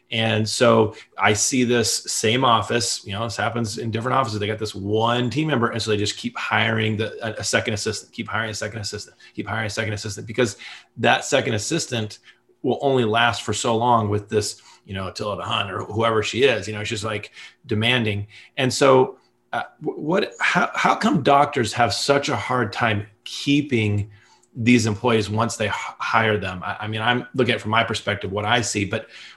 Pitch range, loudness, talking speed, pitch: 105-120 Hz, -21 LUFS, 205 wpm, 110 Hz